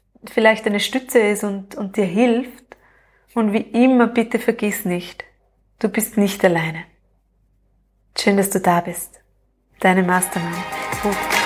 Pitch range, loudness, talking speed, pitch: 180-230 Hz, -19 LUFS, 135 wpm, 205 Hz